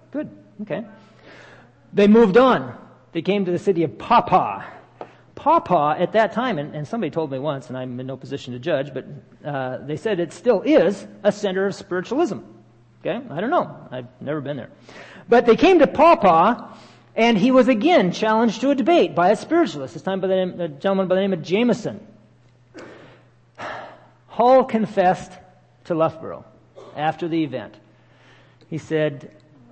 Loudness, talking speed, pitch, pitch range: -20 LUFS, 170 wpm, 185 Hz, 150-225 Hz